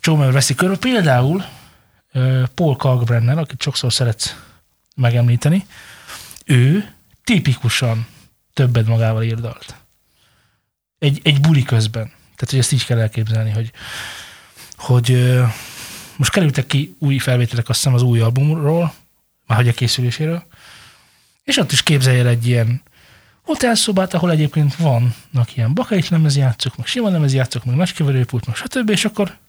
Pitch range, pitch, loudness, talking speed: 120-155 Hz, 130 Hz, -17 LUFS, 140 wpm